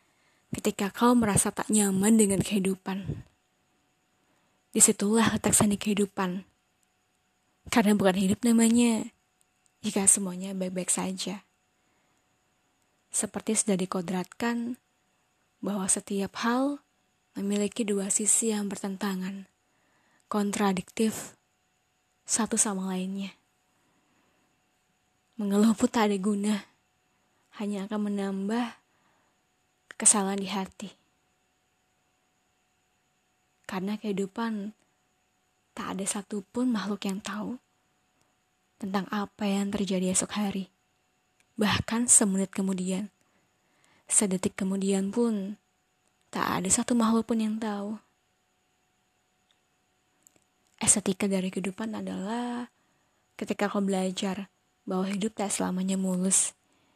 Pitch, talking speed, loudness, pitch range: 200 Hz, 90 wpm, -27 LUFS, 190-215 Hz